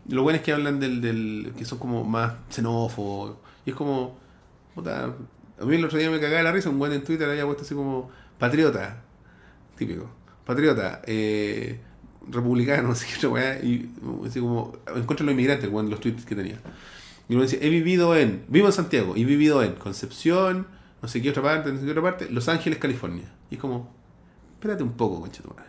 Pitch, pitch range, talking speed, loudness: 130 Hz, 115-150 Hz, 205 wpm, -25 LUFS